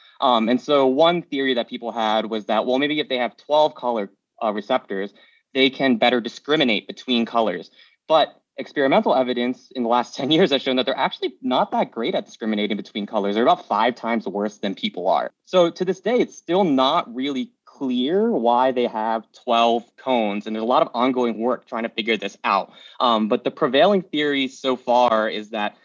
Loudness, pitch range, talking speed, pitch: -21 LUFS, 110-135 Hz, 205 wpm, 125 Hz